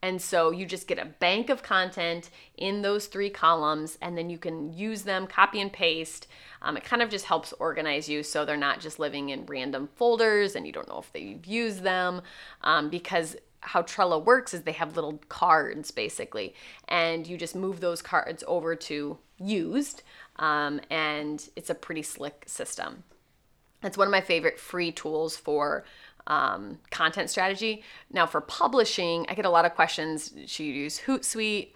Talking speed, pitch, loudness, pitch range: 185 wpm, 175 Hz, -28 LUFS, 155-200 Hz